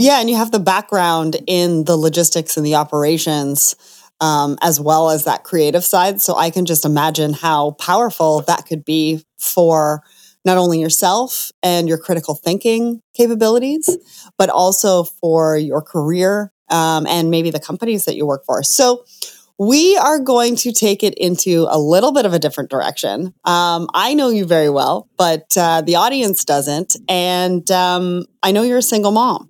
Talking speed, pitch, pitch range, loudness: 175 wpm, 175 Hz, 160-210 Hz, -15 LUFS